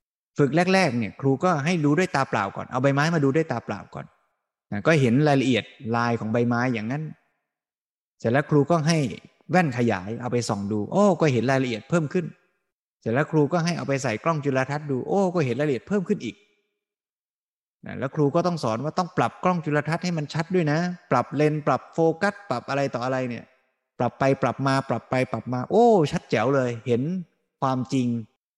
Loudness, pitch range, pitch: -24 LUFS, 125-170 Hz, 140 Hz